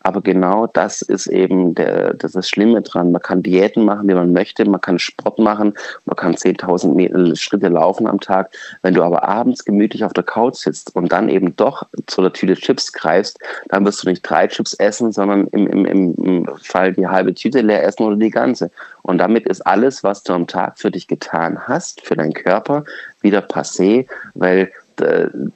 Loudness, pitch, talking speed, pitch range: -16 LUFS, 95 Hz, 200 wpm, 90-105 Hz